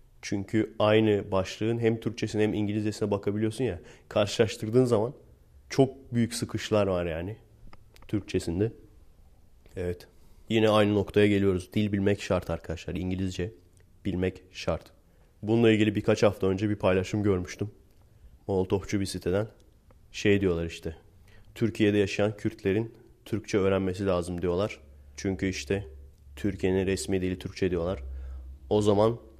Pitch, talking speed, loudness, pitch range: 100 Hz, 120 wpm, -28 LUFS, 90-105 Hz